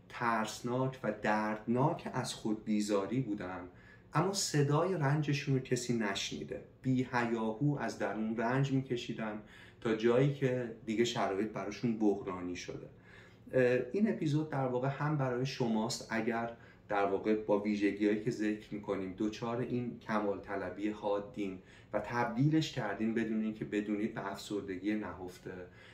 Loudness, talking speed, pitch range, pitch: -35 LUFS, 130 wpm, 105-125 Hz, 110 Hz